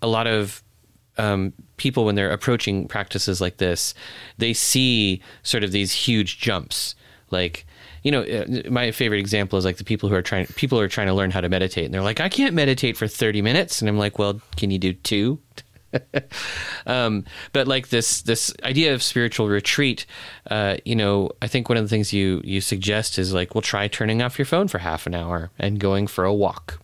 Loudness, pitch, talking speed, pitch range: -22 LUFS, 105 Hz, 210 wpm, 95-115 Hz